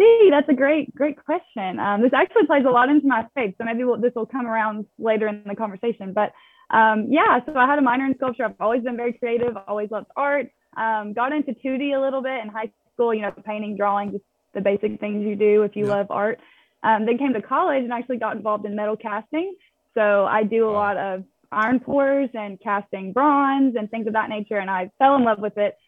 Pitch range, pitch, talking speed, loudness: 210-265 Hz, 225 Hz, 235 wpm, -21 LUFS